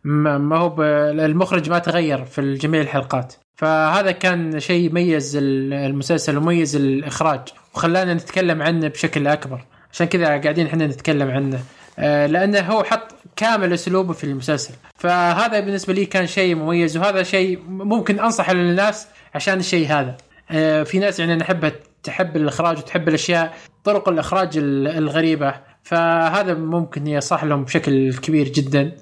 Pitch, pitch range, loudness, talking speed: 165 Hz, 150-180 Hz, -19 LUFS, 135 wpm